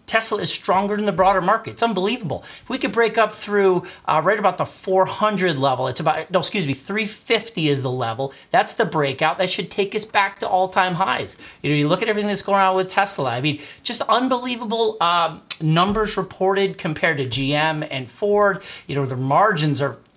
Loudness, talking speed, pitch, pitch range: -20 LUFS, 210 wpm, 190 Hz, 155-210 Hz